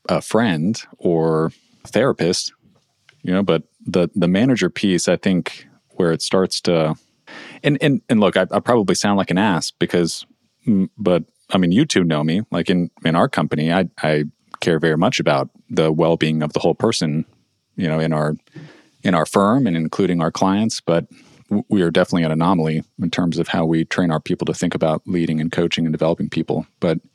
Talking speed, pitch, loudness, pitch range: 200 wpm, 80 Hz, -19 LUFS, 80-90 Hz